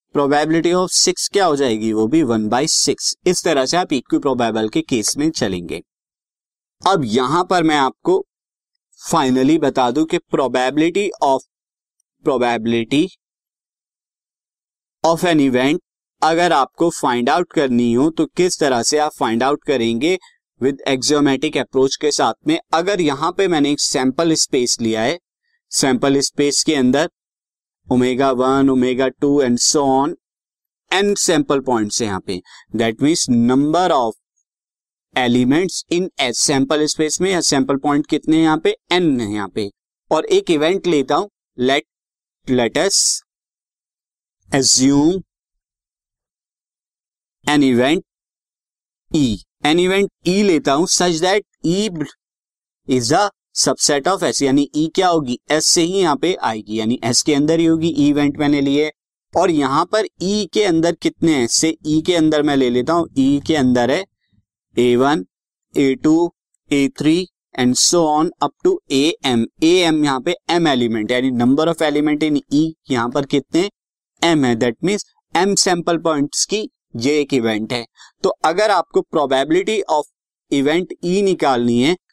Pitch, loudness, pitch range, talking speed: 150 Hz, -17 LUFS, 130-170 Hz, 140 wpm